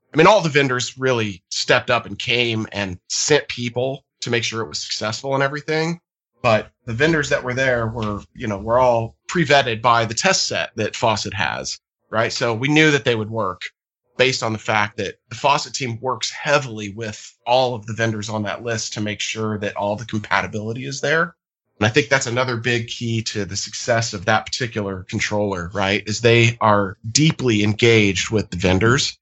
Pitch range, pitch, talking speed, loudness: 105-130 Hz, 115 Hz, 200 wpm, -19 LUFS